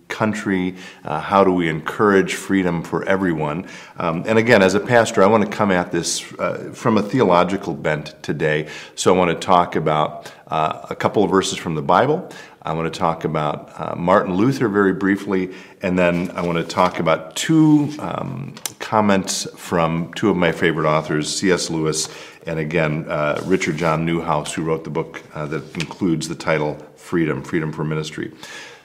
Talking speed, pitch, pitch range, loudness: 185 wpm, 85 Hz, 80-95 Hz, -19 LUFS